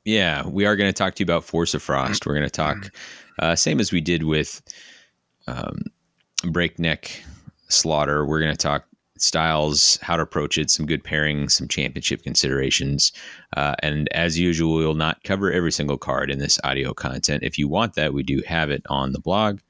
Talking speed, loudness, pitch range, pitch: 200 wpm, -21 LUFS, 75-85 Hz, 75 Hz